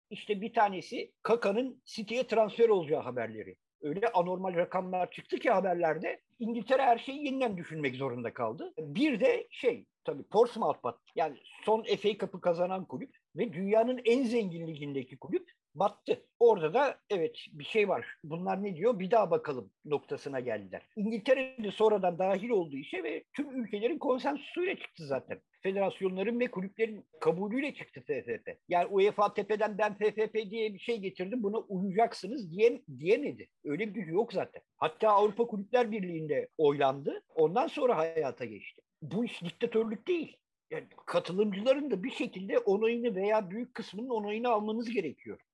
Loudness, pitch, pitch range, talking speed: -32 LUFS, 225 Hz, 190-265 Hz, 150 wpm